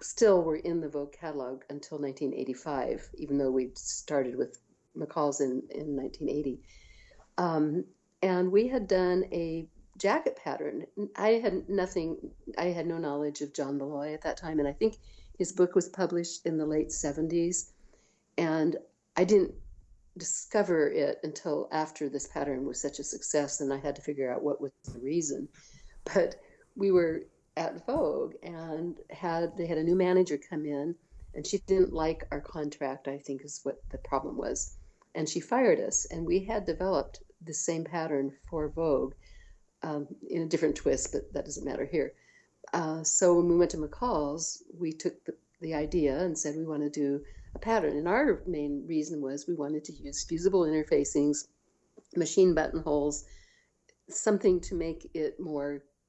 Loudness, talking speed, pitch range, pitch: -31 LUFS, 170 wpm, 145-175 Hz, 160 Hz